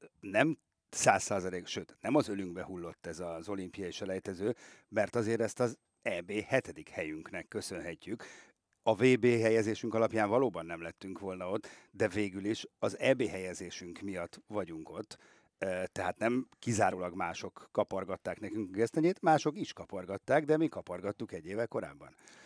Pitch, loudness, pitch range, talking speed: 100 Hz, -34 LUFS, 90-115 Hz, 145 wpm